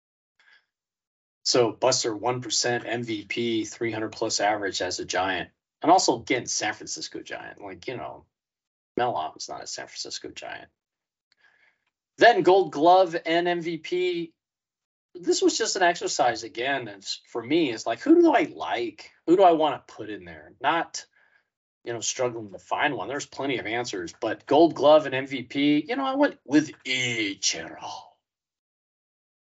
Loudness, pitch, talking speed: -24 LUFS, 150 Hz, 155 wpm